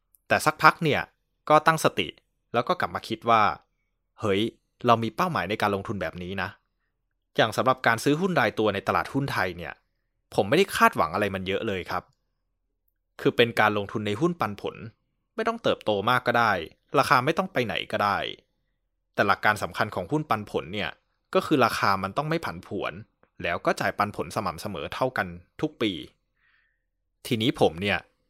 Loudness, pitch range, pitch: -25 LUFS, 100-145 Hz, 115 Hz